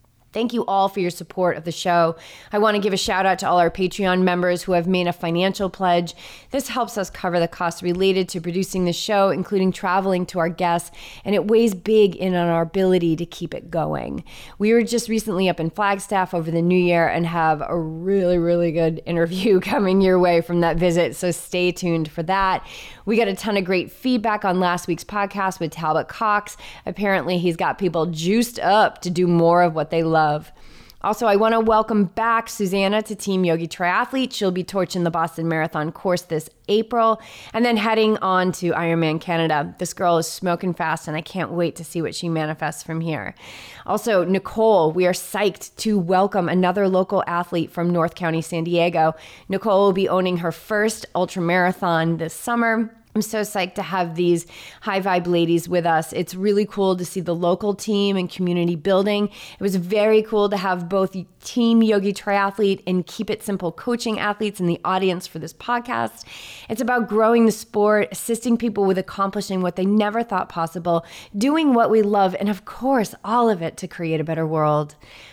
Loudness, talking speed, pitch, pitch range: -21 LUFS, 200 wpm, 185 Hz, 170-205 Hz